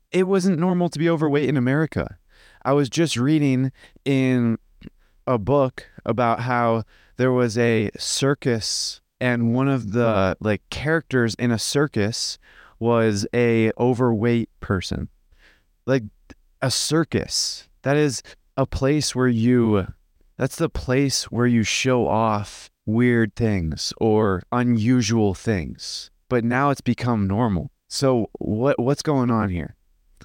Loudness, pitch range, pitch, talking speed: -22 LUFS, 105-135 Hz, 120 Hz, 130 wpm